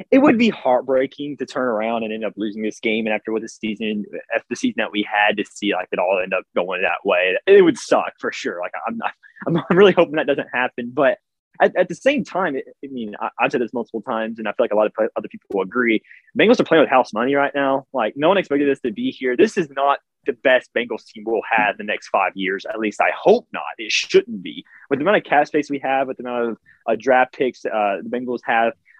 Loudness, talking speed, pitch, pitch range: -20 LUFS, 275 wpm, 130 Hz, 110-170 Hz